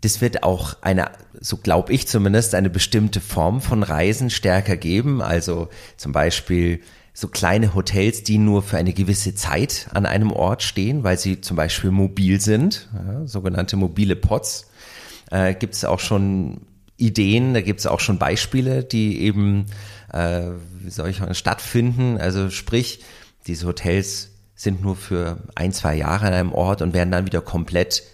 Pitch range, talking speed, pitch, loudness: 90-110 Hz, 170 wpm, 100 Hz, -20 LUFS